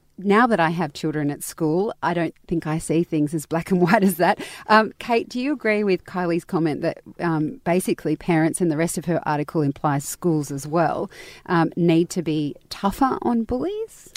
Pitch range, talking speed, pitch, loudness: 160-200 Hz, 205 wpm, 170 Hz, -22 LUFS